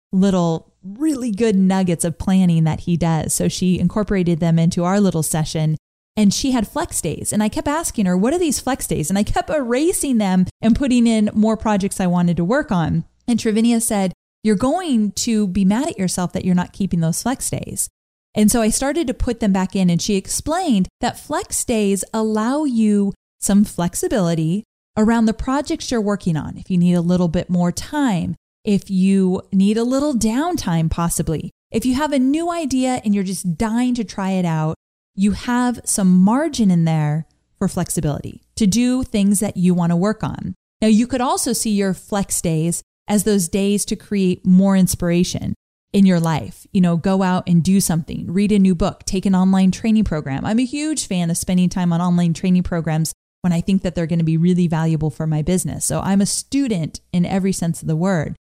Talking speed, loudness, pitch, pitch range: 210 wpm, -18 LUFS, 195 Hz, 175-225 Hz